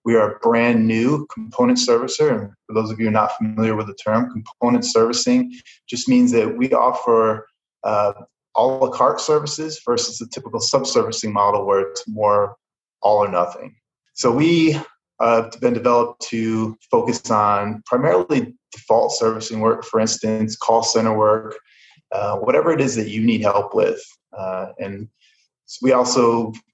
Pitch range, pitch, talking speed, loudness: 110-125 Hz, 115 Hz, 165 wpm, -19 LUFS